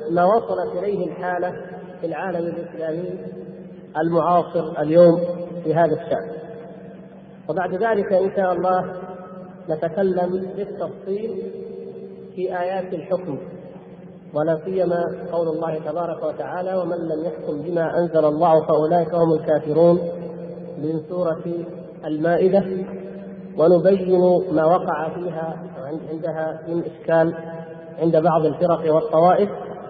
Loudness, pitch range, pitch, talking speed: -21 LUFS, 160-180 Hz, 170 Hz, 100 wpm